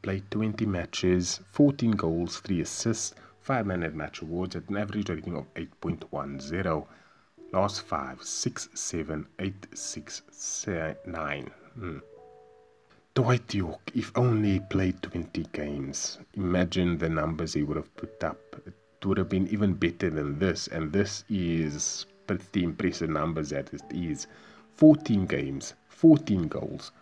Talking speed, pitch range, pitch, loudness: 140 wpm, 80-105 Hz, 90 Hz, -29 LUFS